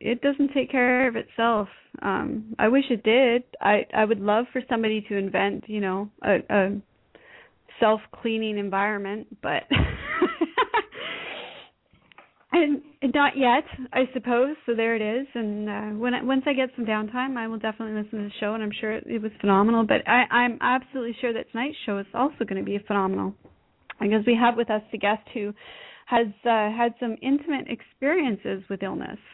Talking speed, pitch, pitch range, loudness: 180 wpm, 230 Hz, 210-255 Hz, -25 LUFS